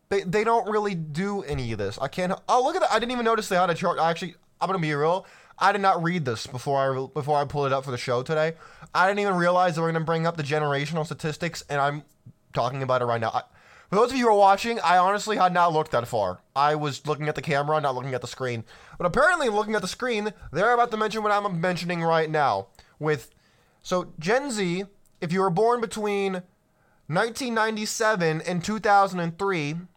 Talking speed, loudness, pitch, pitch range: 235 wpm, -25 LUFS, 175 Hz, 150-200 Hz